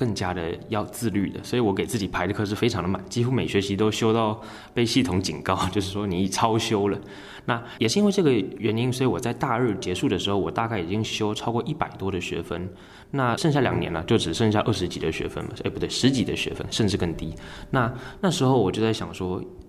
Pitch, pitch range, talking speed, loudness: 105 Hz, 95-120 Hz, 345 characters per minute, -25 LUFS